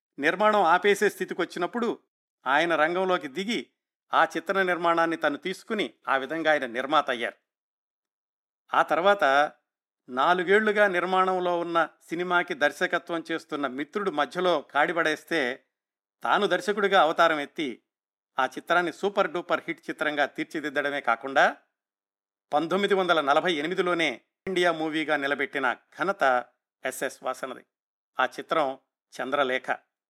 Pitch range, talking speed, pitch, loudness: 145-180 Hz, 105 wpm, 165 Hz, -26 LUFS